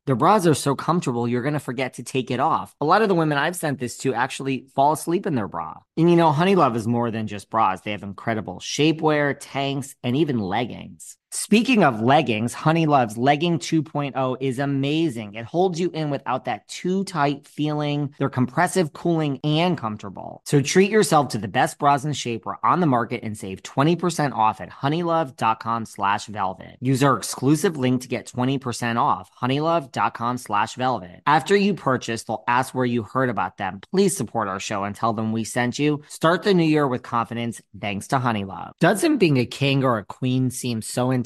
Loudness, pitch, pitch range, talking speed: -22 LUFS, 130 Hz, 115-155 Hz, 200 wpm